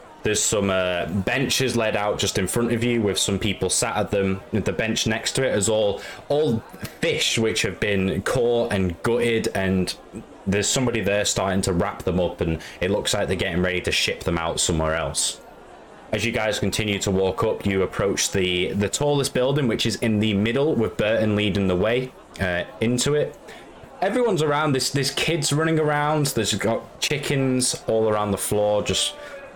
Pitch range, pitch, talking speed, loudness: 95-125 Hz, 110 Hz, 195 wpm, -22 LUFS